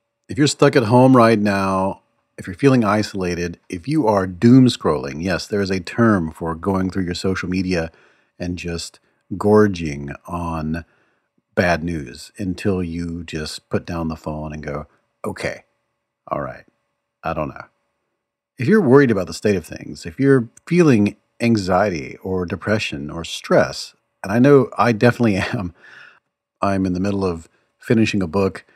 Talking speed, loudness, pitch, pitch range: 165 wpm, -19 LUFS, 95 Hz, 85-115 Hz